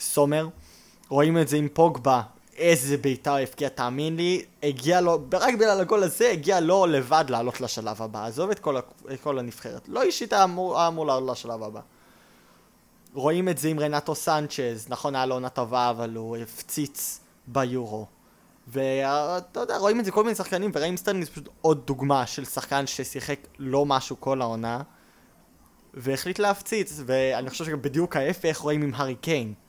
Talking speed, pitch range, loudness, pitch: 165 wpm, 130-170 Hz, -25 LUFS, 145 Hz